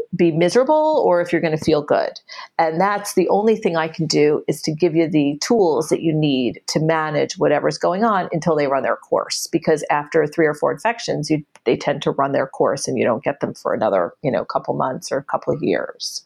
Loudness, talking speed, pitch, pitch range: -19 LUFS, 240 wpm, 165 Hz, 155-180 Hz